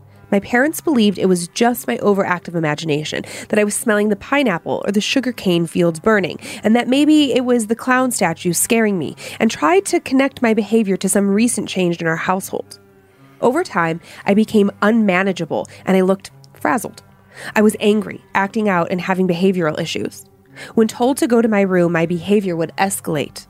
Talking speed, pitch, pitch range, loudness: 185 wpm, 200 Hz, 170-225 Hz, -17 LUFS